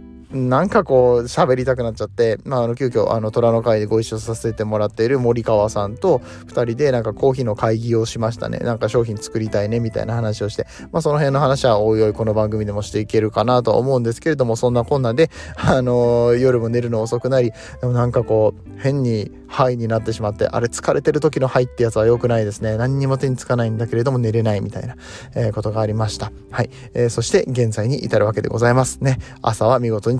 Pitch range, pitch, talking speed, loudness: 110-130 Hz, 115 Hz, 470 characters per minute, -19 LUFS